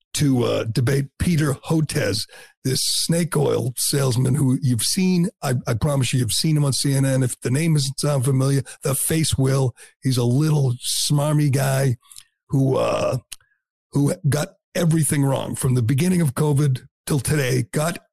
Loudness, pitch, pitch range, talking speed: -21 LUFS, 140 Hz, 130-150 Hz, 155 wpm